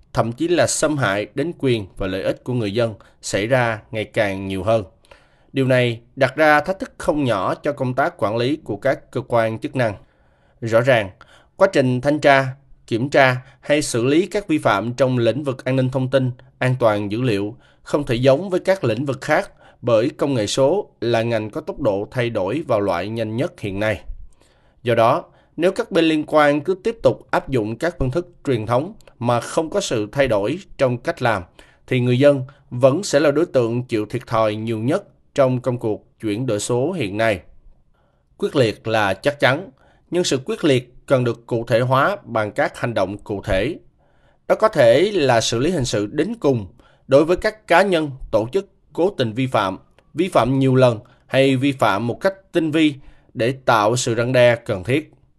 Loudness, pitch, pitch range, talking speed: -19 LUFS, 130 Hz, 115-145 Hz, 210 wpm